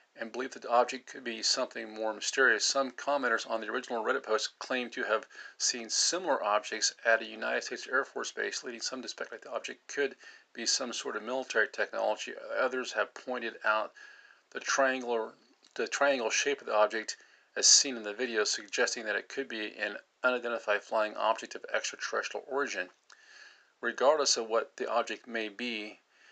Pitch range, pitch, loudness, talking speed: 110-130 Hz, 115 Hz, -31 LUFS, 180 wpm